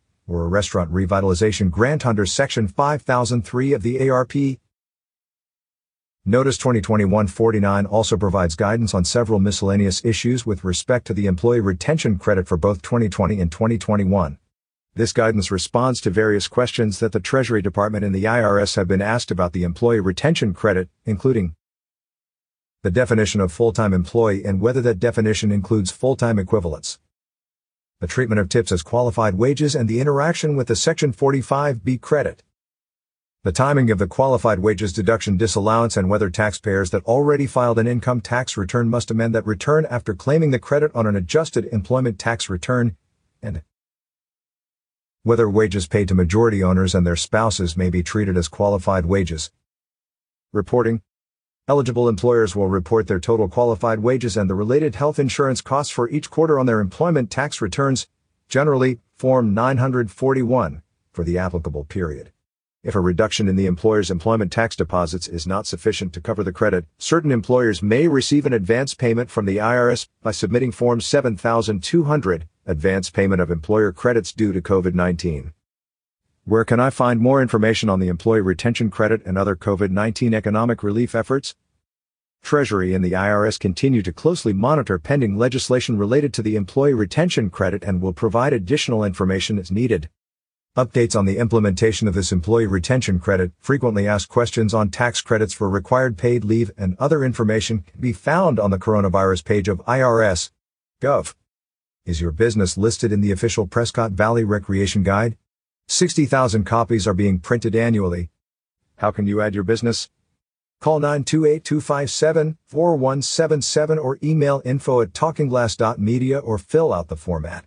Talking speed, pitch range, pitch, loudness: 155 wpm, 95-125 Hz, 110 Hz, -19 LUFS